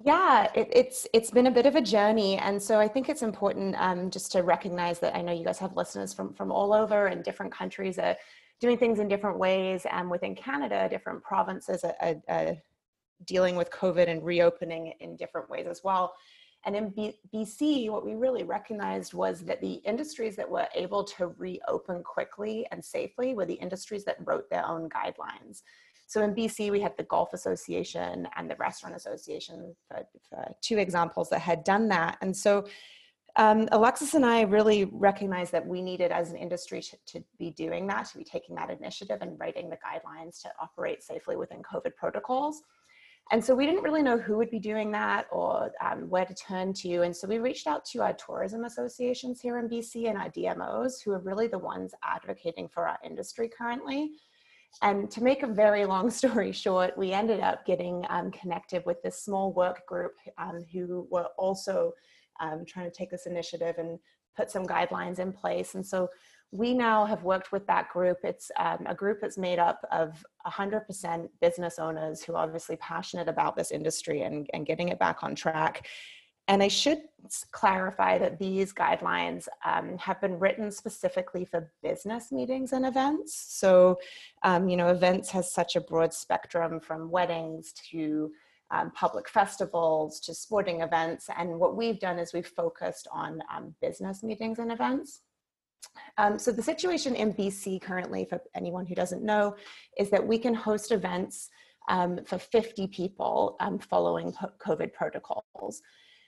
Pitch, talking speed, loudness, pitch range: 195 Hz, 185 wpm, -29 LUFS, 175-230 Hz